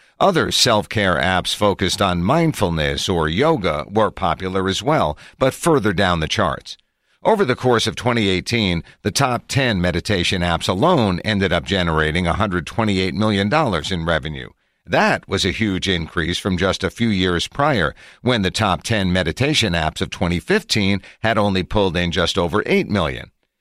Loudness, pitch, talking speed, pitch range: -18 LUFS, 95 Hz, 160 wpm, 85-105 Hz